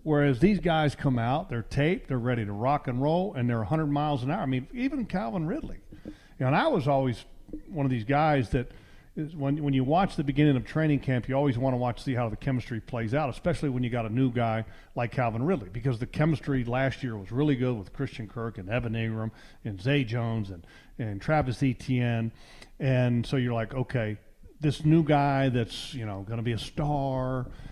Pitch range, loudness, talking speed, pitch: 115-145 Hz, -28 LUFS, 225 wpm, 130 Hz